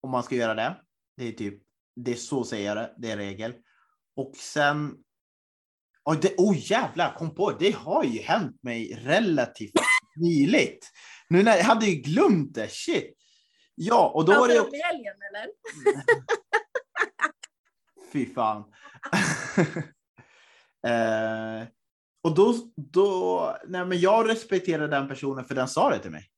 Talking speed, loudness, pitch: 145 wpm, -25 LUFS, 160 Hz